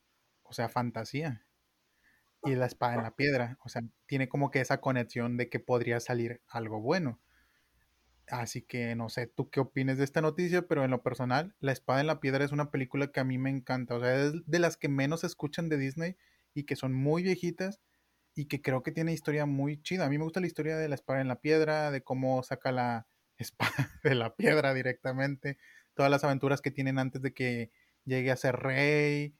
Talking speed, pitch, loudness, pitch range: 215 wpm, 135 Hz, -32 LUFS, 125-150 Hz